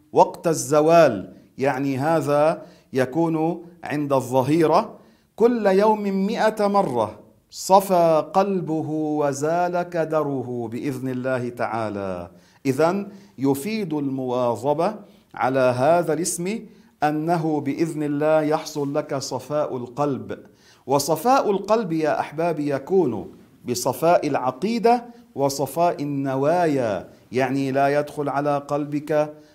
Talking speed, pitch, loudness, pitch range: 90 wpm, 150 Hz, -22 LUFS, 135-175 Hz